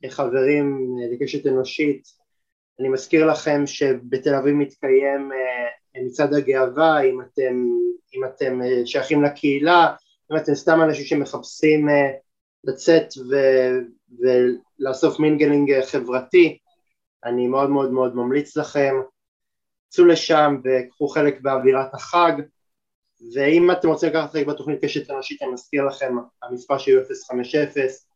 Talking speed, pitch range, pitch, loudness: 115 wpm, 130-155 Hz, 140 Hz, -20 LUFS